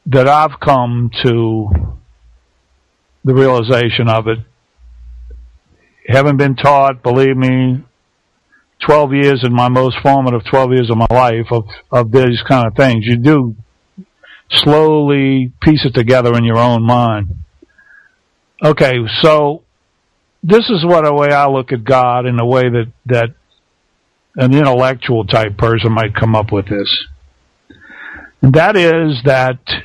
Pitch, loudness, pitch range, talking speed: 125 Hz, -12 LUFS, 110-135 Hz, 140 wpm